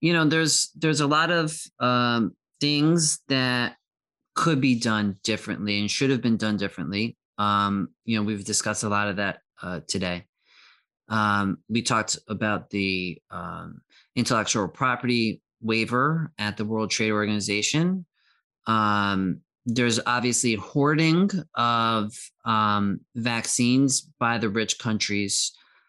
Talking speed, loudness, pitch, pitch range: 130 wpm, -24 LUFS, 115 Hz, 105-135 Hz